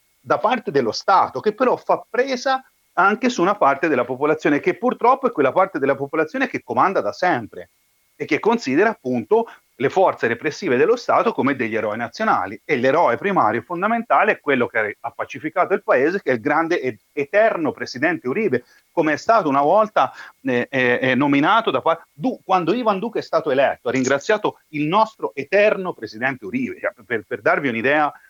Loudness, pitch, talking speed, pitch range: -20 LUFS, 185 Hz, 180 wpm, 140-230 Hz